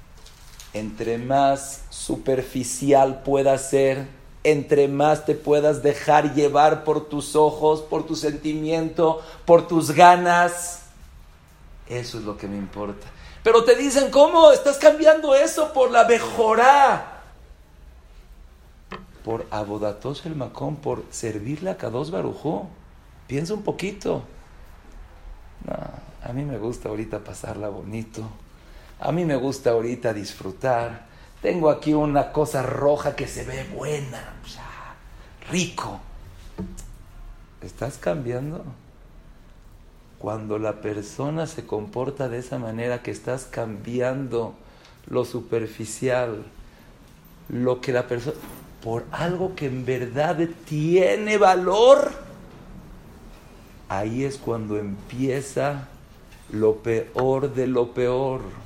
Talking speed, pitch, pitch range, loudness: 110 wpm, 130 Hz, 105-150 Hz, -22 LUFS